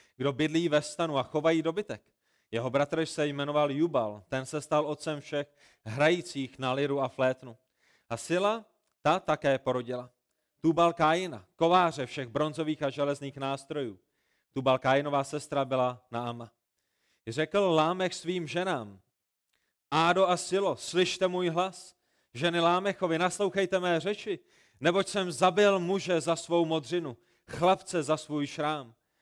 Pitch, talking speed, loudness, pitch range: 155 Hz, 135 wpm, -29 LUFS, 135-175 Hz